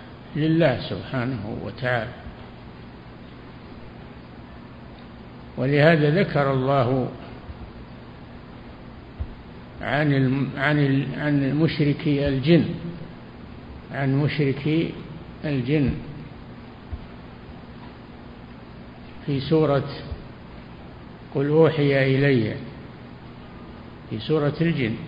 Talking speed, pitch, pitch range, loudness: 55 wpm, 135 Hz, 115-150 Hz, -22 LUFS